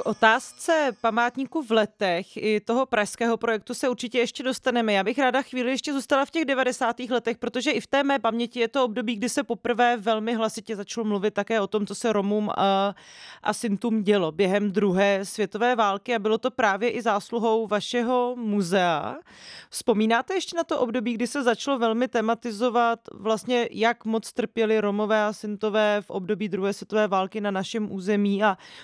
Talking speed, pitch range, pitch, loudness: 180 wpm, 210-245 Hz, 225 Hz, -25 LUFS